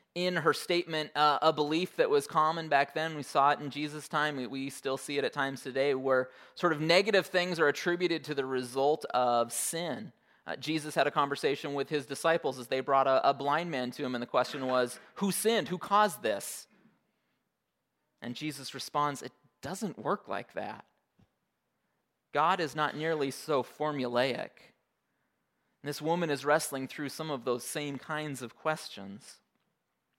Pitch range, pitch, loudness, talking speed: 135-160 Hz, 145 Hz, -31 LUFS, 180 wpm